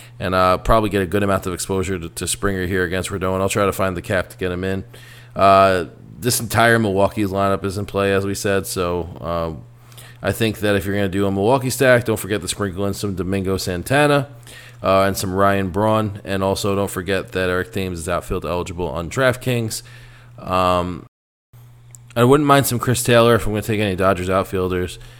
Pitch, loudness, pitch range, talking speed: 100 Hz, -19 LUFS, 95-115 Hz, 210 wpm